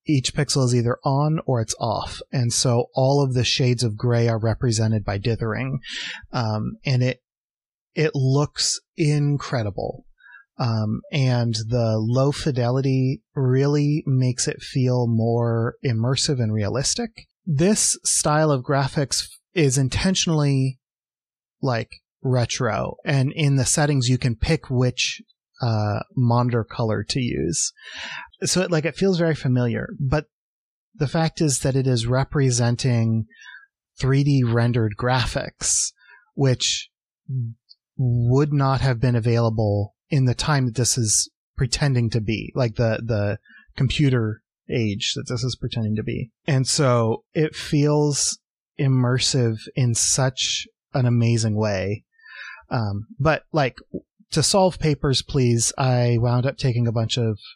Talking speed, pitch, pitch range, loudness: 135 wpm, 125 Hz, 115-145 Hz, -22 LUFS